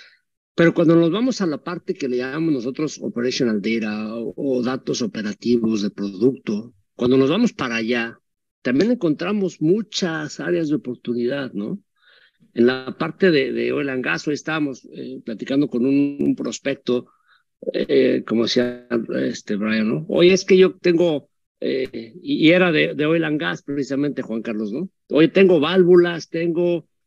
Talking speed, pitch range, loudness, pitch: 165 wpm, 120-170 Hz, -20 LUFS, 140 Hz